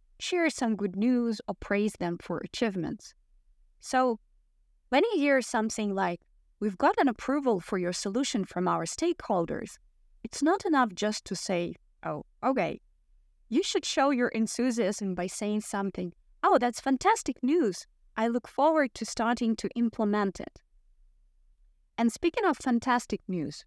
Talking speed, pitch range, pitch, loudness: 145 wpm, 200-265 Hz, 230 Hz, -29 LUFS